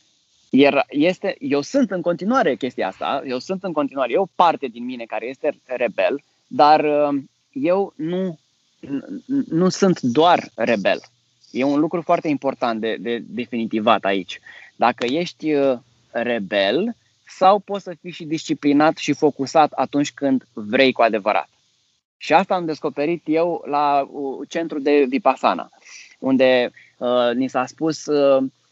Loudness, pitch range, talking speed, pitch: -20 LUFS, 130-175 Hz, 140 wpm, 145 Hz